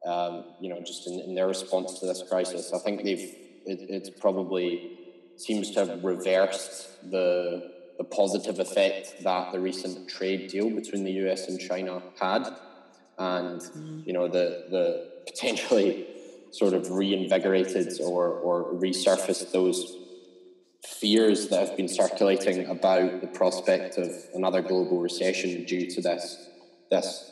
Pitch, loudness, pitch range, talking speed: 95 Hz, -28 LUFS, 90-95 Hz, 140 wpm